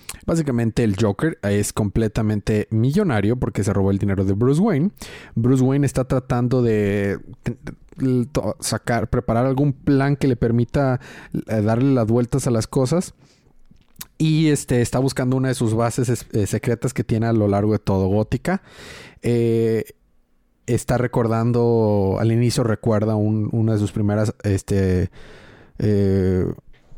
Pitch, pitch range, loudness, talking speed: 115 Hz, 105-130 Hz, -20 LUFS, 140 wpm